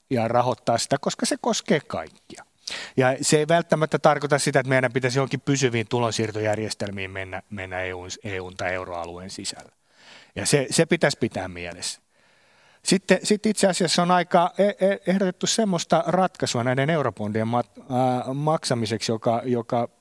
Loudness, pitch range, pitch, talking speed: -23 LUFS, 110-170 Hz, 130 Hz, 140 wpm